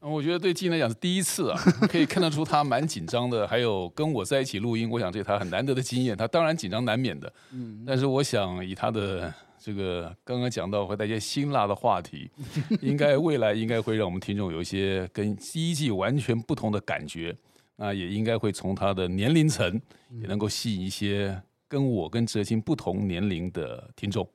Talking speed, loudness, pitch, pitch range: 320 characters per minute, -27 LUFS, 110 Hz, 100-140 Hz